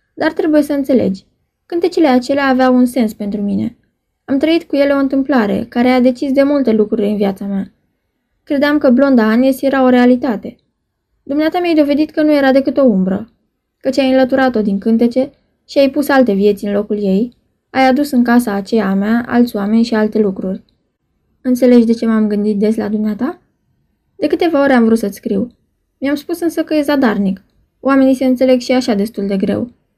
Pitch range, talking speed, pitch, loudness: 215-280 Hz, 190 wpm, 255 Hz, -14 LUFS